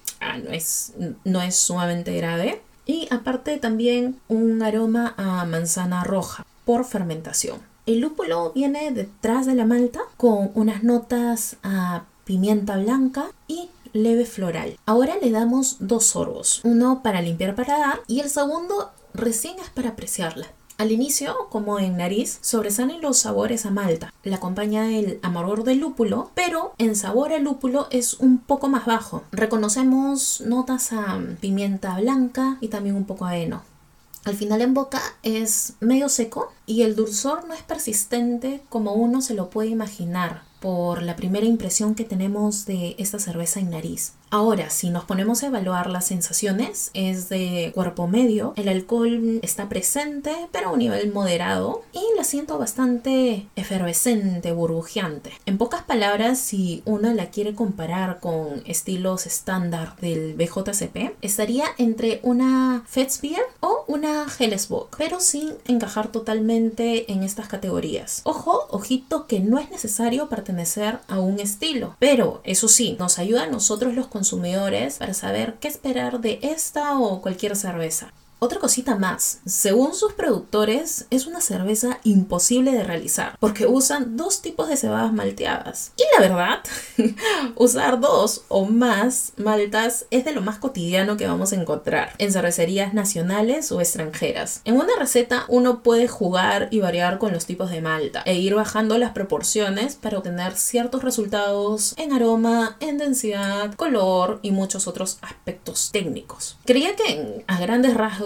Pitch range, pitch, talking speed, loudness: 195-250 Hz, 225 Hz, 155 wpm, -22 LUFS